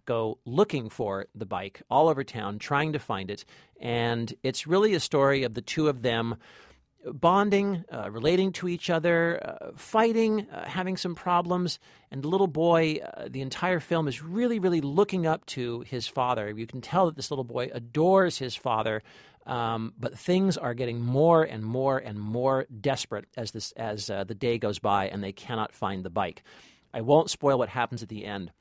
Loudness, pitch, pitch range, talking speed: -27 LUFS, 135 Hz, 115-170 Hz, 195 wpm